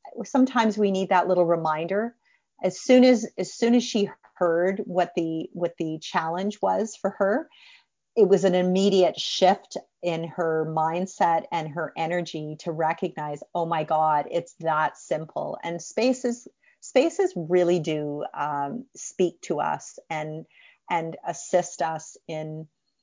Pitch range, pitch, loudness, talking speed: 160-200 Hz, 175 Hz, -25 LUFS, 145 wpm